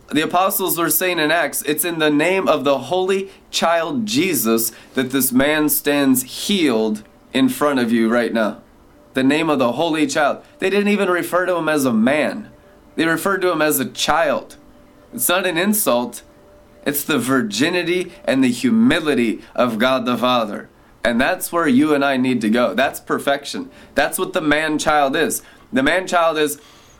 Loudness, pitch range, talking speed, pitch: -18 LUFS, 135-185 Hz, 180 wpm, 155 Hz